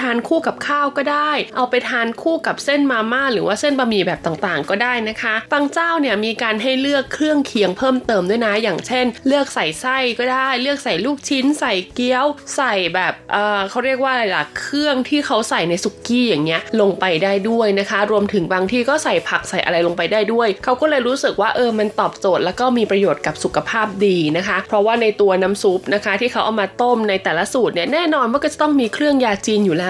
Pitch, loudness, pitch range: 230 Hz, -17 LUFS, 200-270 Hz